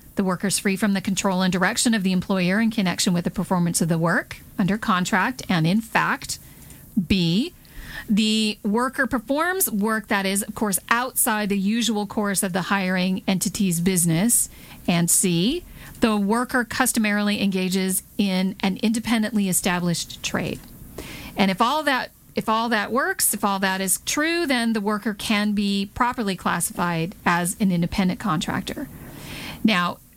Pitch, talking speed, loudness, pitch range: 205 Hz, 155 wpm, -22 LUFS, 185-225 Hz